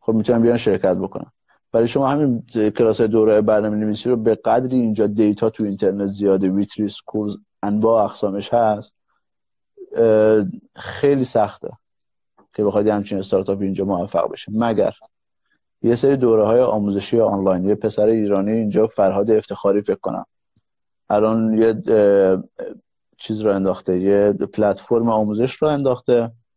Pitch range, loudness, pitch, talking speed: 100-115 Hz, -18 LUFS, 110 Hz, 135 wpm